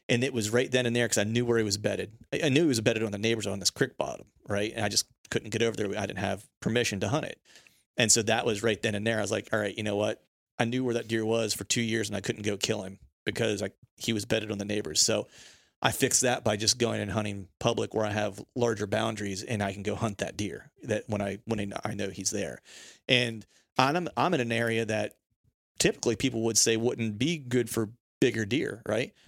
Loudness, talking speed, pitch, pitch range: -29 LUFS, 260 wpm, 110 Hz, 105-120 Hz